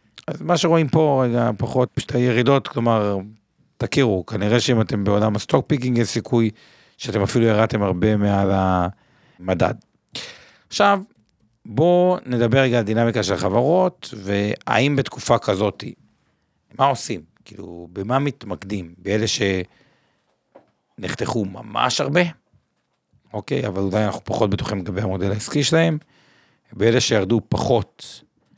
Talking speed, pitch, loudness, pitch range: 120 wpm, 115 Hz, -20 LUFS, 100-135 Hz